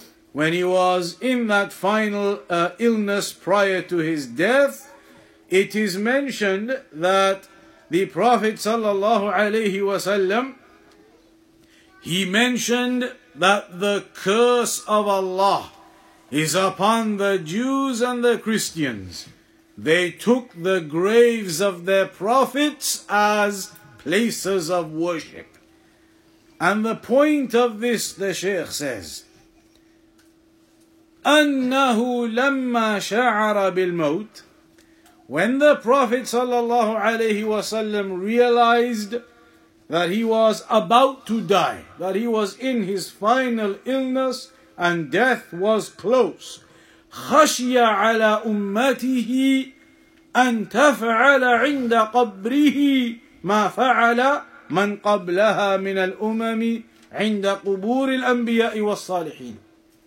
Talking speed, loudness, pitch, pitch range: 100 wpm, -20 LUFS, 225 Hz, 195-255 Hz